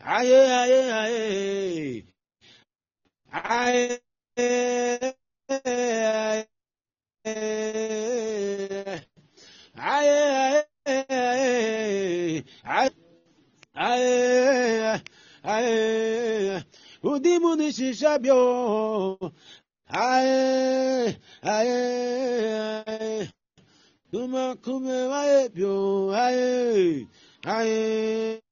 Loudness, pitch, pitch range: -24 LUFS, 240 Hz, 215-260 Hz